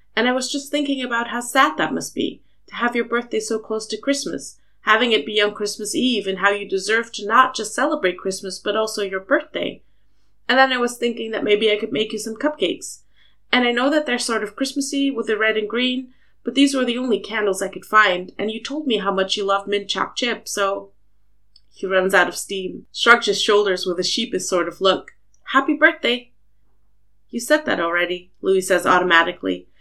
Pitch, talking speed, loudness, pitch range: 215 Hz, 215 wpm, -20 LUFS, 185-240 Hz